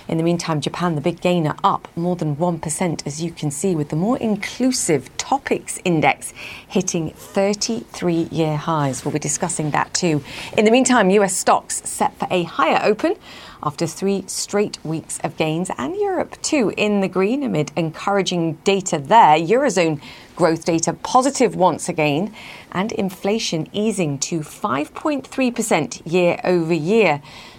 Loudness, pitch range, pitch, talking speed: -20 LUFS, 160-205 Hz, 180 Hz, 150 wpm